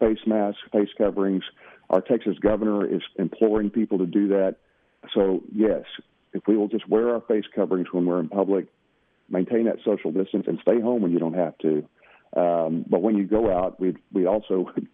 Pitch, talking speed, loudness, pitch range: 100 Hz, 195 wpm, -24 LUFS, 90-110 Hz